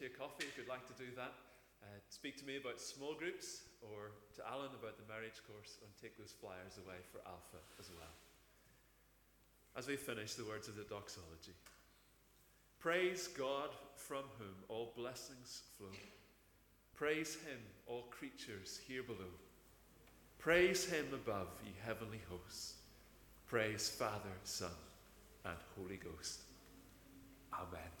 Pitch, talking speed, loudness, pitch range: 110 Hz, 140 wpm, -46 LUFS, 95-130 Hz